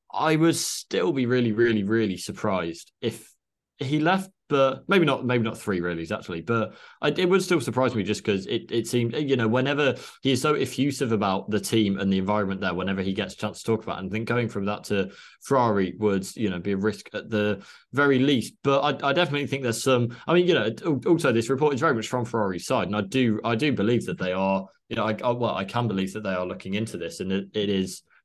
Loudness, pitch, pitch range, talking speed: -25 LUFS, 115 Hz, 100-135 Hz, 255 wpm